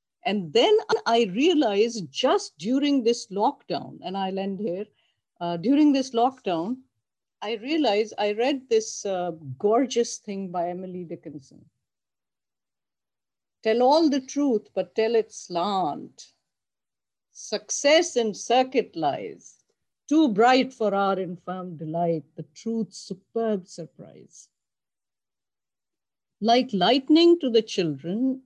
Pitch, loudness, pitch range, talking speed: 220 Hz, -24 LUFS, 185-255 Hz, 115 wpm